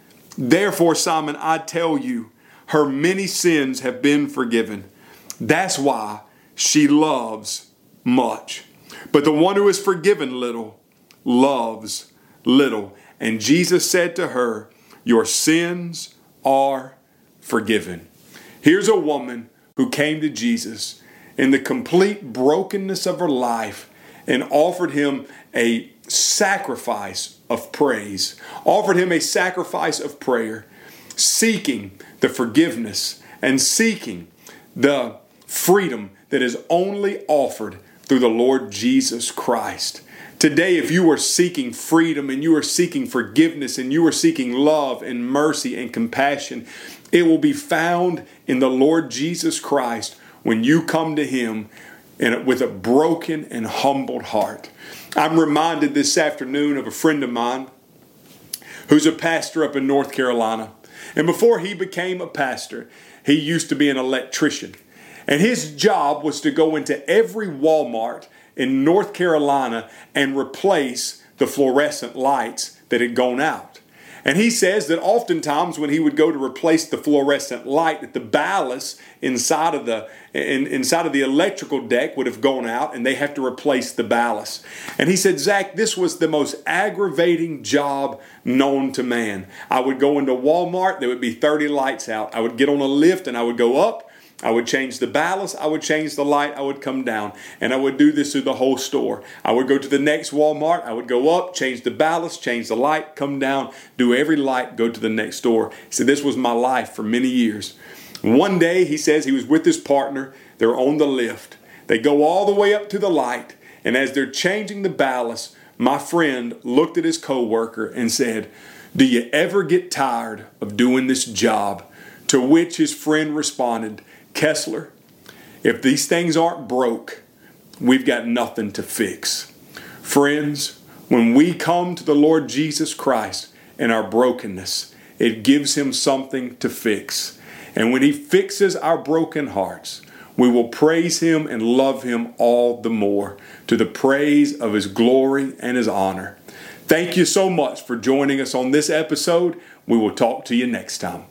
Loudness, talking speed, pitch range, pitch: -19 LUFS, 165 wpm, 125-165 Hz, 145 Hz